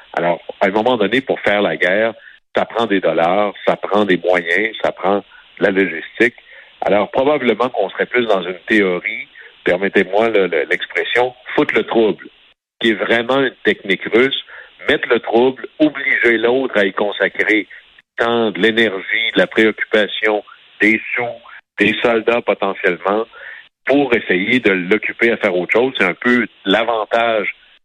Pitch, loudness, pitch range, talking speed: 115 Hz, -16 LUFS, 105-120 Hz, 160 wpm